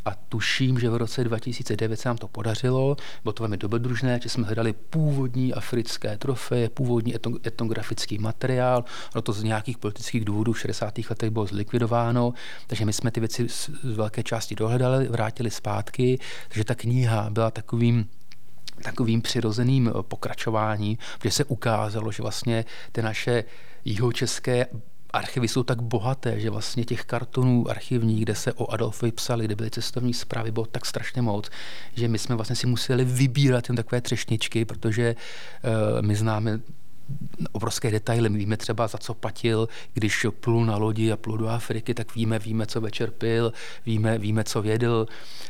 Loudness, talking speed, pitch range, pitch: -26 LUFS, 160 wpm, 110-125 Hz, 115 Hz